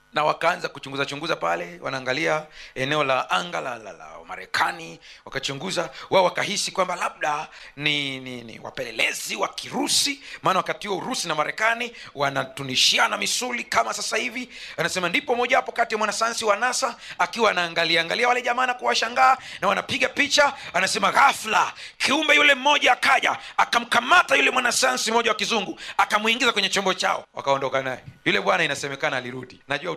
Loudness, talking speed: -22 LUFS, 130 wpm